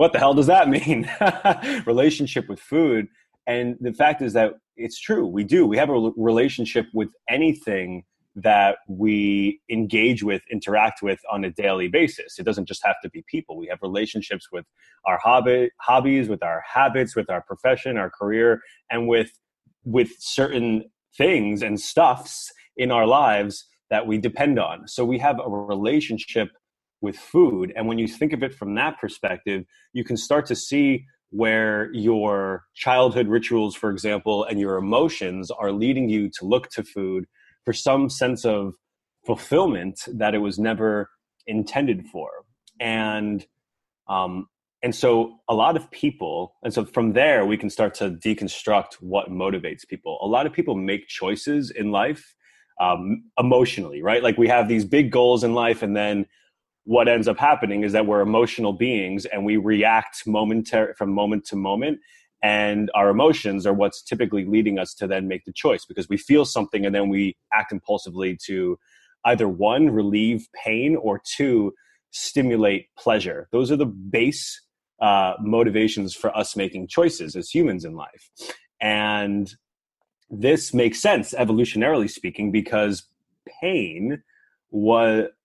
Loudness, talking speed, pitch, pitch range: -22 LUFS, 160 wpm, 110 Hz, 100-120 Hz